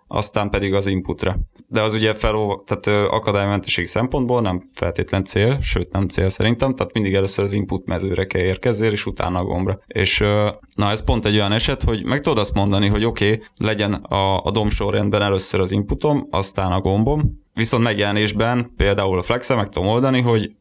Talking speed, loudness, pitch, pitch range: 185 wpm, -19 LUFS, 105 Hz, 95-110 Hz